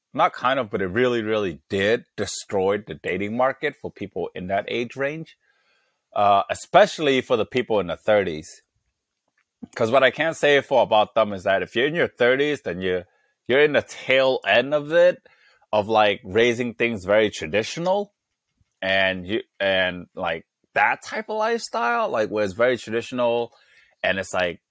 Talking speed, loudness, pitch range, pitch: 175 wpm, -22 LUFS, 105-145 Hz, 120 Hz